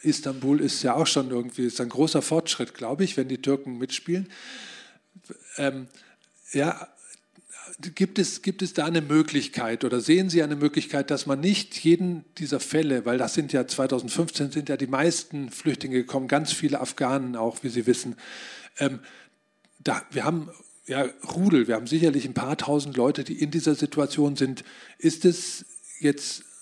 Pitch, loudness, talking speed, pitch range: 145 Hz, -25 LUFS, 170 wpm, 135-165 Hz